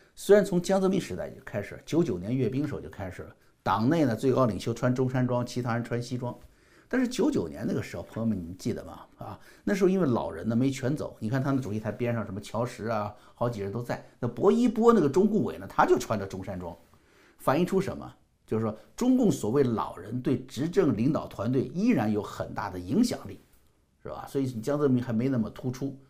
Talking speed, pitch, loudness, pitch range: 340 characters per minute, 120 Hz, -28 LUFS, 105-140 Hz